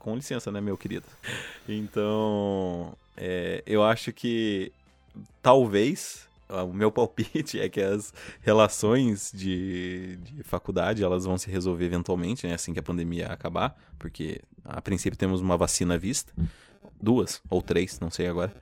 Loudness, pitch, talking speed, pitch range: -28 LUFS, 95 Hz, 150 wpm, 90-105 Hz